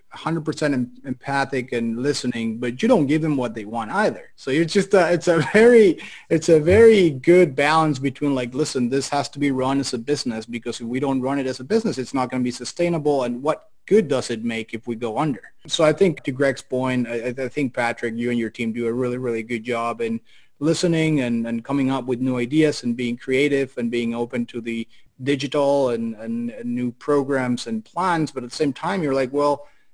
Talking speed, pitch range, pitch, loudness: 230 wpm, 120-150 Hz, 130 Hz, -21 LUFS